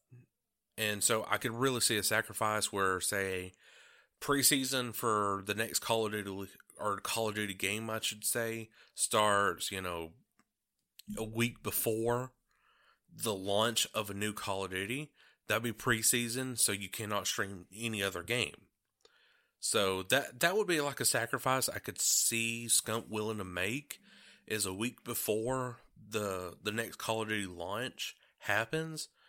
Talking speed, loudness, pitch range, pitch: 155 wpm, -33 LUFS, 100-120 Hz, 110 Hz